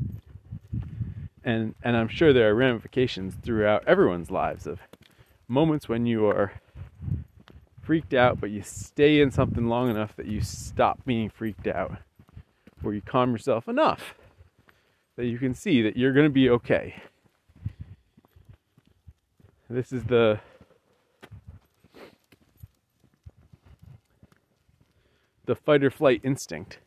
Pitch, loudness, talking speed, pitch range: 115 Hz, -25 LUFS, 120 wpm, 105-125 Hz